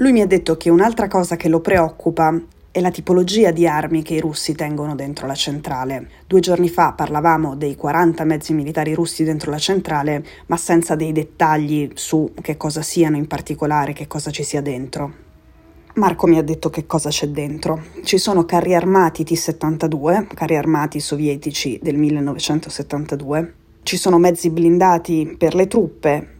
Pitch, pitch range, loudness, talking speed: 160 Hz, 150-170 Hz, -18 LUFS, 170 wpm